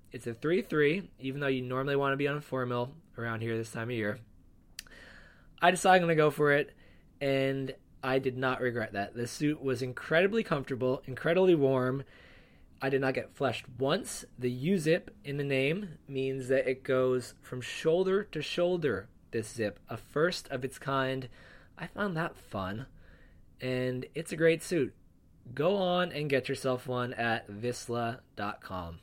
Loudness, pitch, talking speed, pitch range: -31 LUFS, 130 Hz, 180 wpm, 120-150 Hz